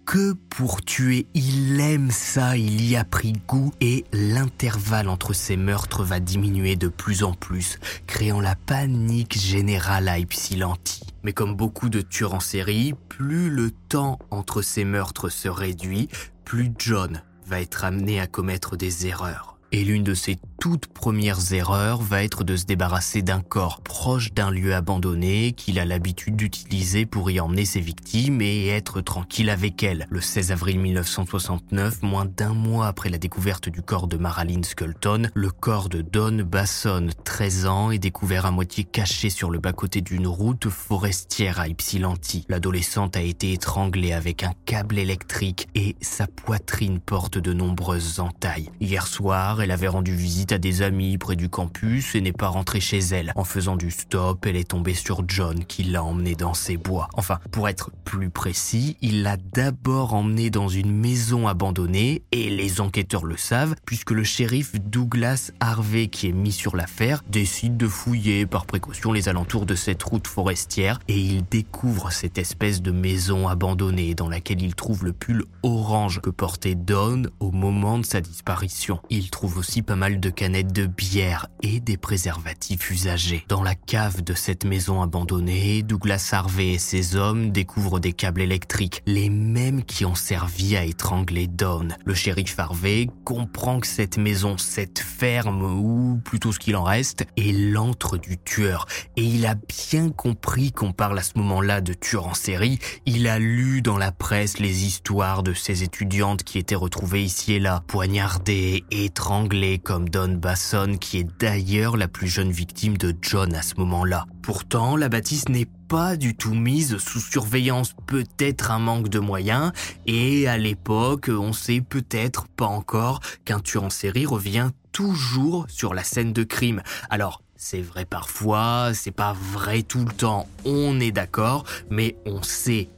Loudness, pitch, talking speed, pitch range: -24 LUFS, 100 Hz, 175 wpm, 90-110 Hz